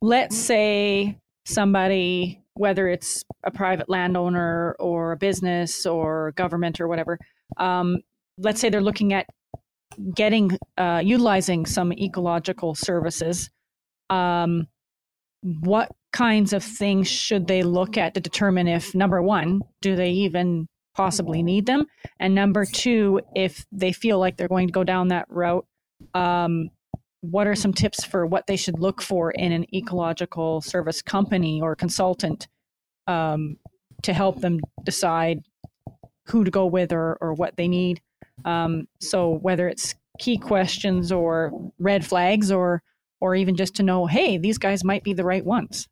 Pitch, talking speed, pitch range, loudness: 185 Hz, 150 wpm, 170-195 Hz, -23 LUFS